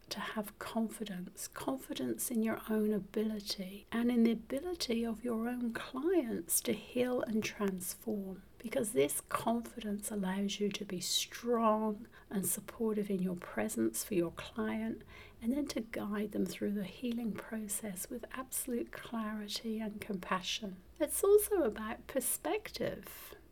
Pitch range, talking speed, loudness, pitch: 200-235 Hz, 140 wpm, -36 LUFS, 220 Hz